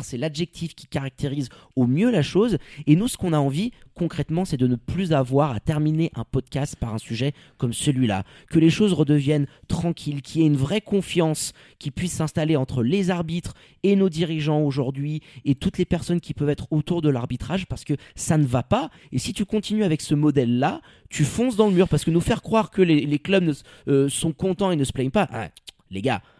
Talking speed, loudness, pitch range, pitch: 220 wpm, -23 LUFS, 140-175 Hz, 150 Hz